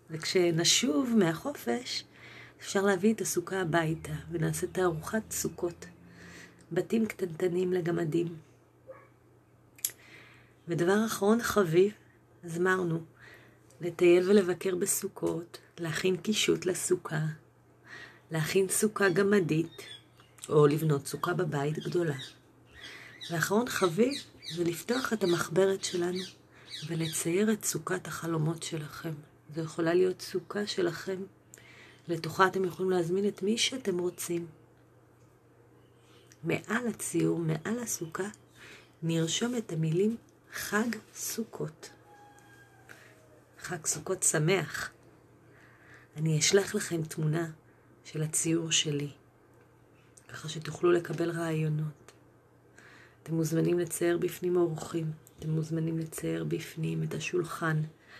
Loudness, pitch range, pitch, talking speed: -30 LUFS, 155-190 Hz, 170 Hz, 95 wpm